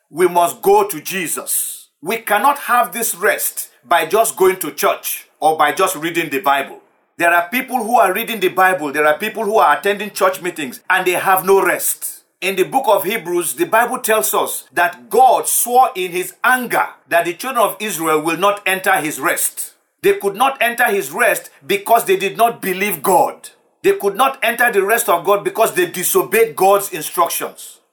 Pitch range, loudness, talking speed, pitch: 180-250 Hz, -16 LUFS, 200 wpm, 205 Hz